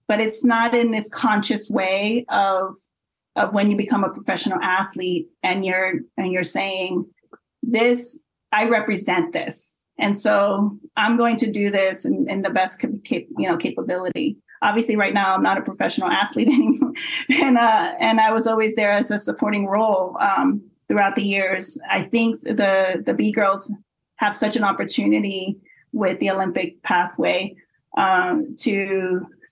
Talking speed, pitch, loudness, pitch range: 160 wpm, 210 Hz, -20 LUFS, 195-240 Hz